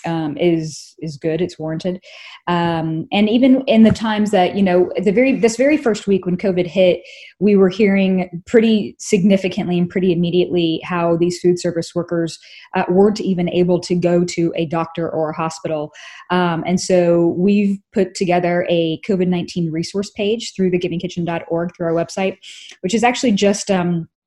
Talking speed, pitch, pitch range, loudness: 175 wpm, 180 Hz, 170-200 Hz, -17 LUFS